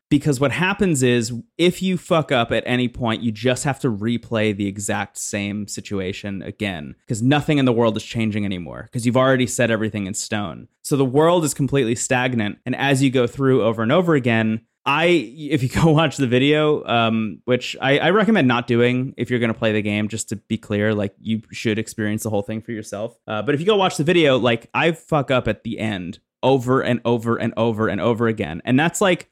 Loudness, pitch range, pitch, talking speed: -20 LUFS, 110-140 Hz, 120 Hz, 225 wpm